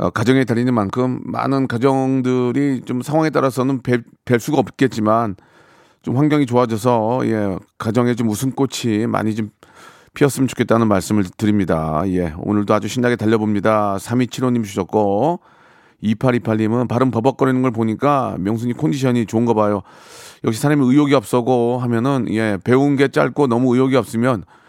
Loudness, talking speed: -18 LUFS, 330 characters per minute